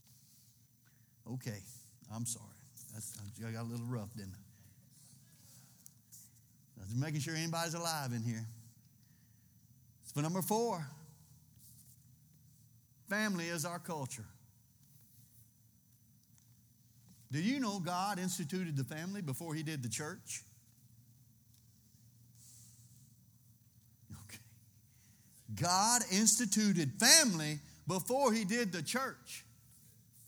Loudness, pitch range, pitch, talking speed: -35 LUFS, 115-155 Hz, 125 Hz, 90 wpm